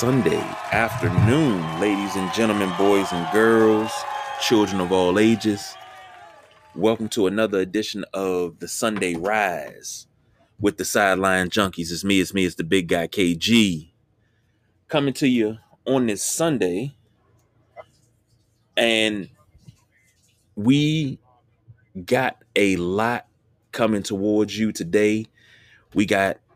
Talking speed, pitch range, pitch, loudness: 115 wpm, 95-115 Hz, 110 Hz, -21 LUFS